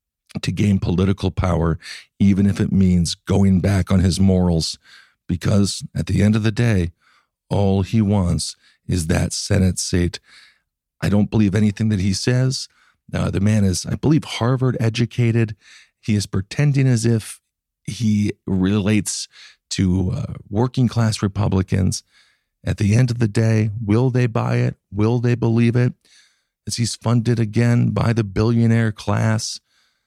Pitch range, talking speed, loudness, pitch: 95-115 Hz, 150 wpm, -19 LUFS, 105 Hz